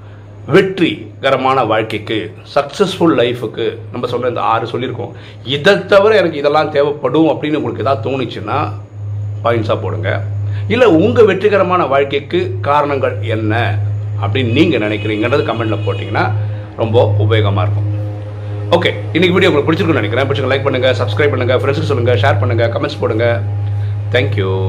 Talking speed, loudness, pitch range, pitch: 110 wpm, -14 LUFS, 105-135 Hz, 110 Hz